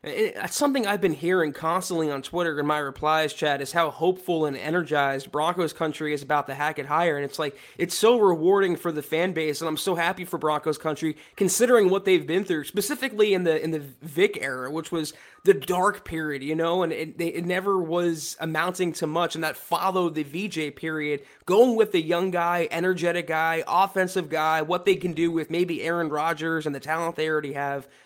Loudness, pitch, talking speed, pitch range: -25 LUFS, 165 Hz, 205 wpm, 155-180 Hz